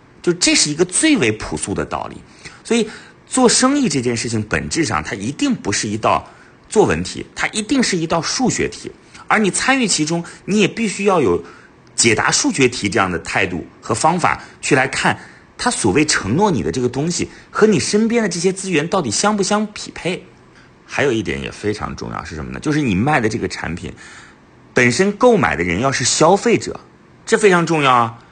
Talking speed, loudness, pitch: 290 characters per minute, -17 LUFS, 180 Hz